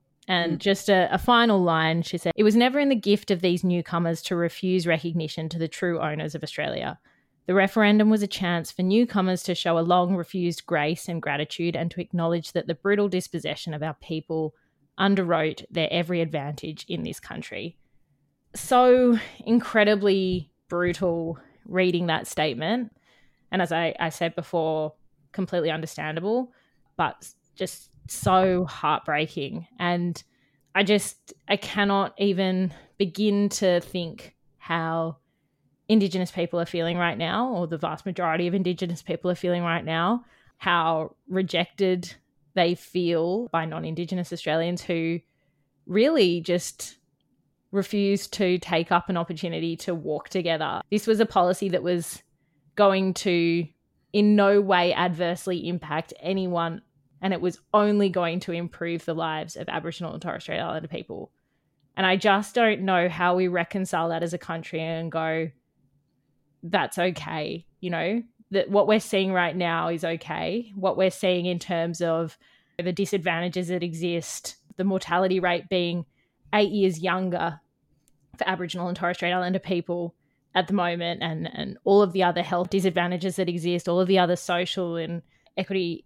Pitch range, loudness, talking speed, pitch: 165-190 Hz, -25 LUFS, 155 wpm, 175 Hz